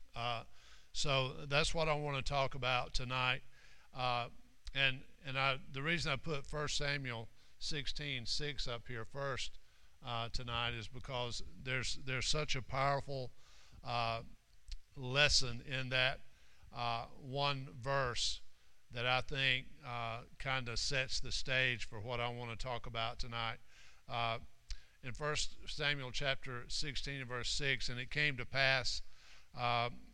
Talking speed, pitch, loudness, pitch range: 140 wpm, 130 Hz, -38 LUFS, 120-140 Hz